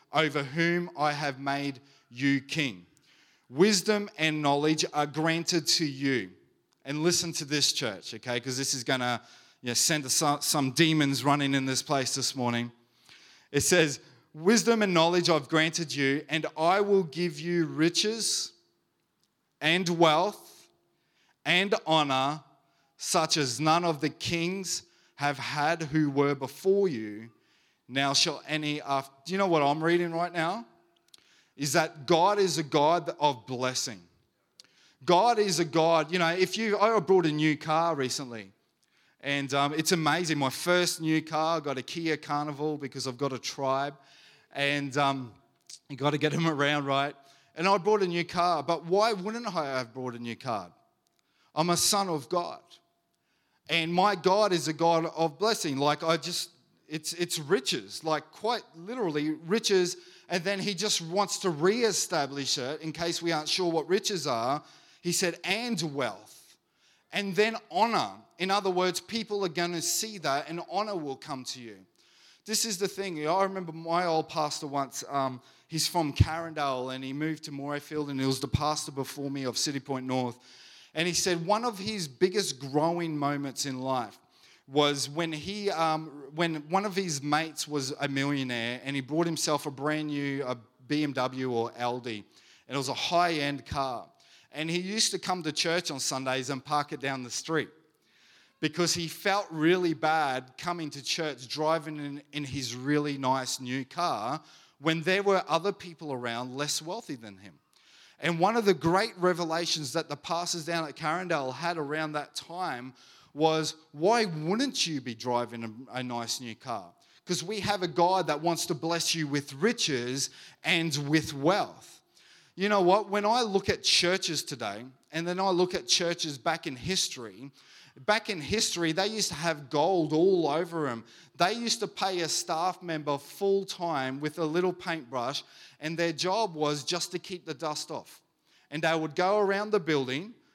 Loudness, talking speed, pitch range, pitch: -28 LUFS, 180 wpm, 140-175 Hz, 155 Hz